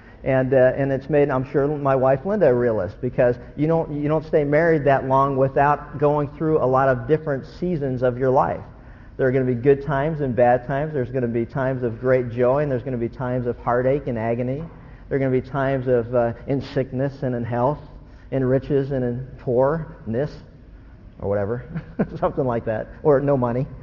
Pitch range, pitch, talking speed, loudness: 125-145 Hz, 130 Hz, 215 wpm, -21 LUFS